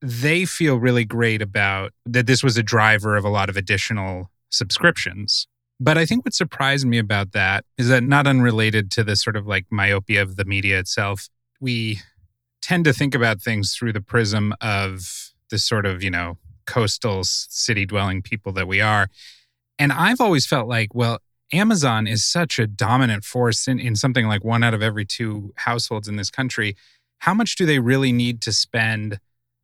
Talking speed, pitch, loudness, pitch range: 190 wpm, 115 Hz, -20 LUFS, 105-125 Hz